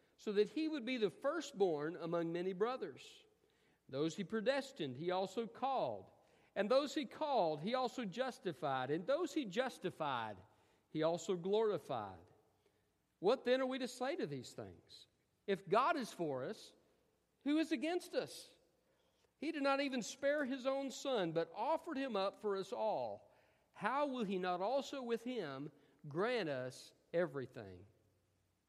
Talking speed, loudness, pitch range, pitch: 155 wpm, -40 LUFS, 165-275 Hz, 225 Hz